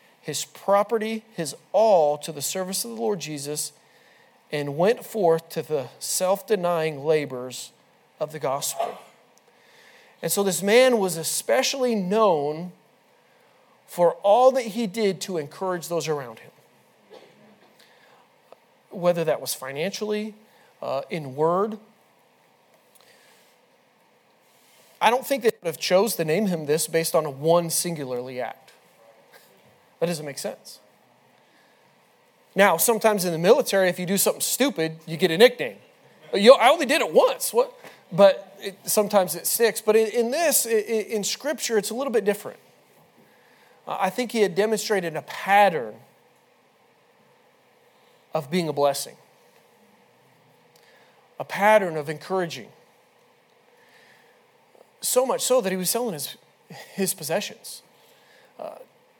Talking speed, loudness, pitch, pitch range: 130 wpm, -23 LUFS, 195 Hz, 165-230 Hz